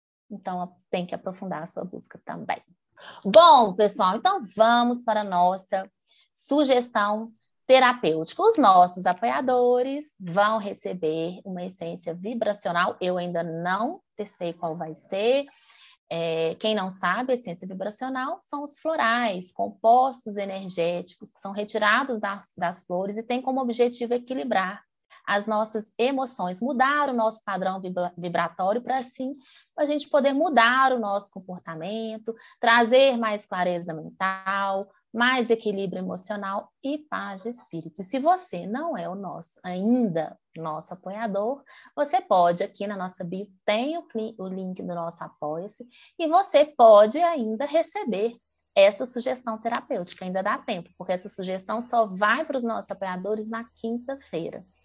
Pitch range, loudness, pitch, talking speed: 185-255 Hz, -24 LUFS, 215 Hz, 140 wpm